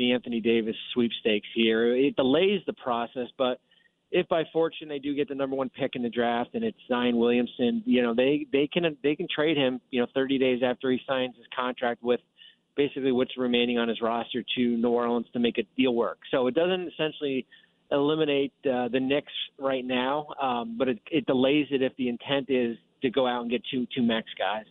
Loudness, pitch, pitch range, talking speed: -27 LUFS, 130 Hz, 120-140 Hz, 215 wpm